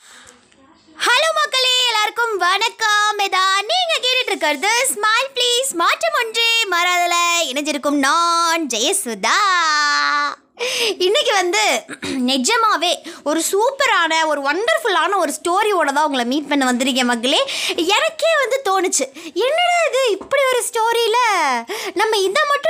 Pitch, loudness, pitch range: 355 Hz, -16 LUFS, 300-435 Hz